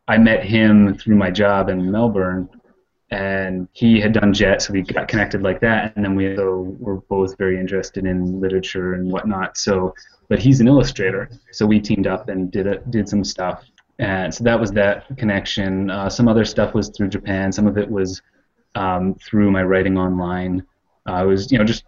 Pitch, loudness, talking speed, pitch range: 100 Hz, -18 LUFS, 205 wpm, 95-105 Hz